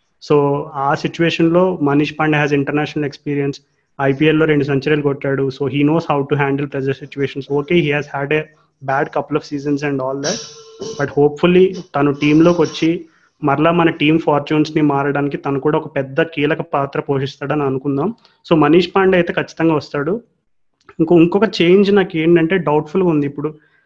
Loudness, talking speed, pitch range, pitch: -16 LUFS, 170 wpm, 140-165 Hz, 150 Hz